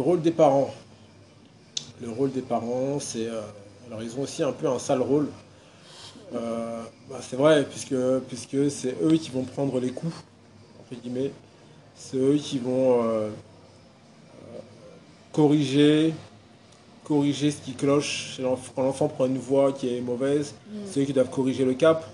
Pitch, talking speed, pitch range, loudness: 130 Hz, 155 wpm, 120-145 Hz, -25 LUFS